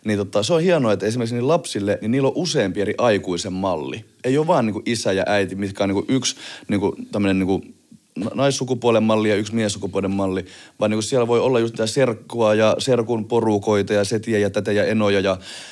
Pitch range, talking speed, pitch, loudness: 100-120 Hz, 210 wpm, 105 Hz, -20 LUFS